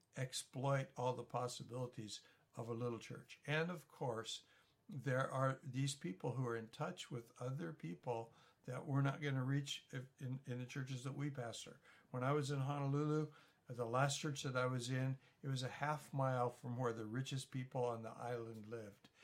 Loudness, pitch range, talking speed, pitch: -44 LUFS, 125-145 Hz, 190 wpm, 130 Hz